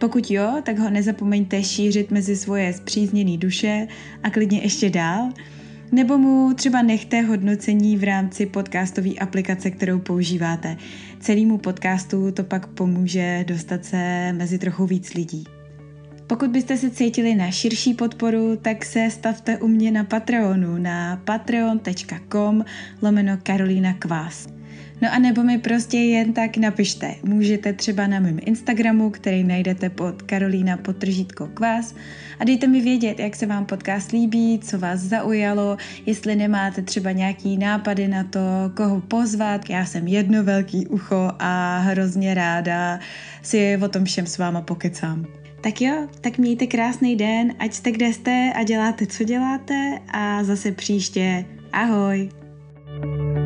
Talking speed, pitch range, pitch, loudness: 145 wpm, 185-225 Hz, 205 Hz, -21 LUFS